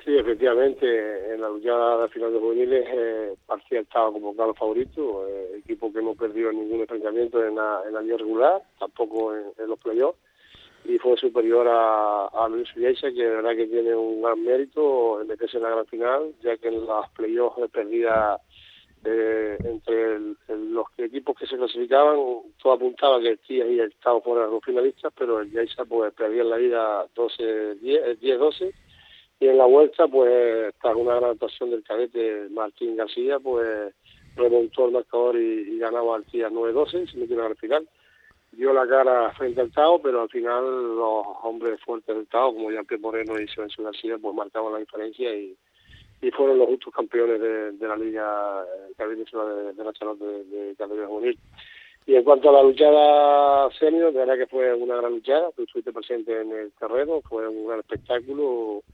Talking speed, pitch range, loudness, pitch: 185 wpm, 110-150 Hz, -23 LUFS, 120 Hz